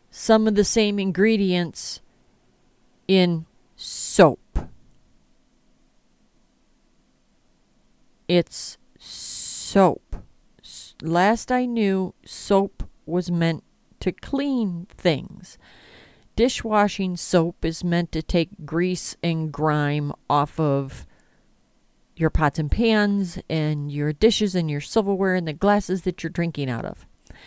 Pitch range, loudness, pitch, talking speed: 160-205 Hz, -23 LUFS, 180 Hz, 105 wpm